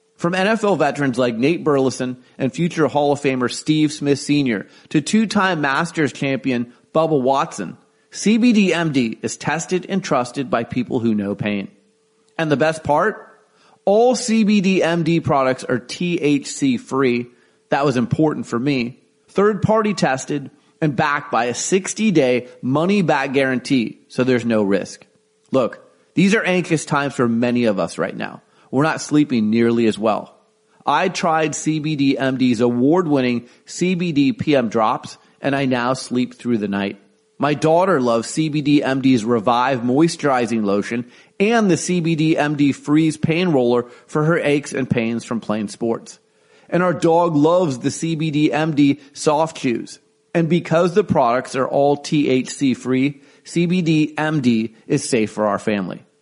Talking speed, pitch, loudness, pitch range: 140 wpm, 145 Hz, -19 LUFS, 125-170 Hz